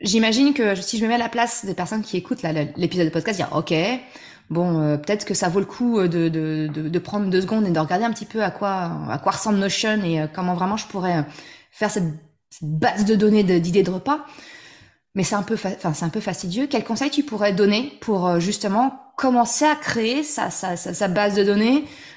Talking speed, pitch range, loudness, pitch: 240 wpm, 175-225 Hz, -21 LUFS, 200 Hz